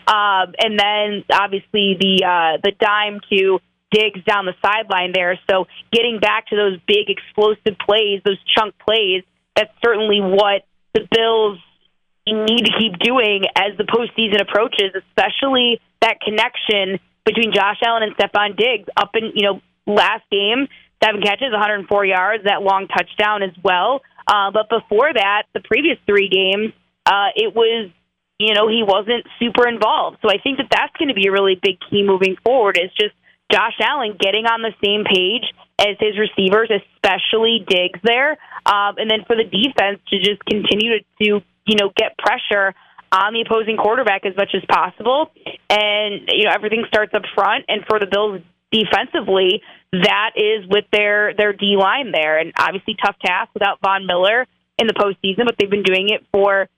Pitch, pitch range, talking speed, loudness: 205 Hz, 195-220 Hz, 180 wpm, -16 LUFS